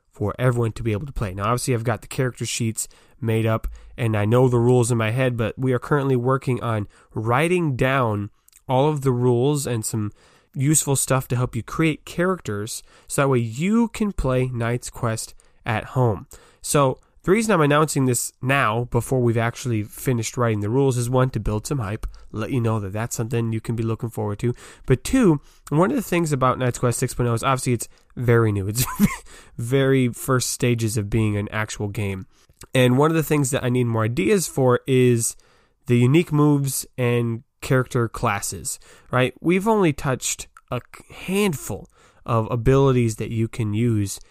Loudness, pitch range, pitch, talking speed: -22 LUFS, 115-135 Hz, 125 Hz, 190 wpm